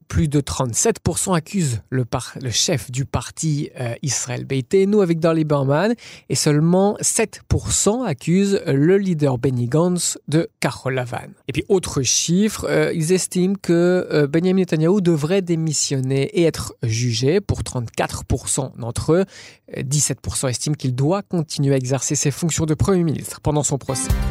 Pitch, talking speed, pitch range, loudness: 150 Hz, 155 wpm, 135-180 Hz, -20 LUFS